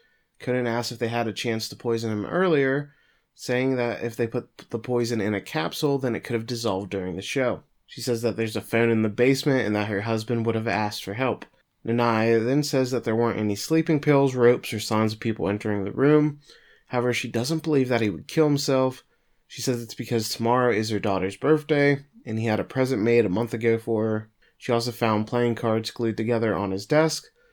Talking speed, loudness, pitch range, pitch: 225 wpm, -24 LUFS, 110-130 Hz, 120 Hz